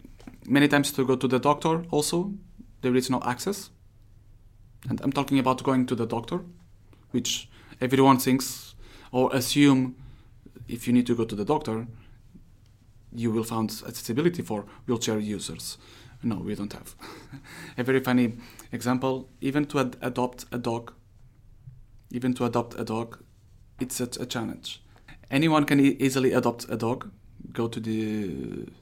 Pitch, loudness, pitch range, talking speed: 120 Hz, -26 LUFS, 110-130 Hz, 150 wpm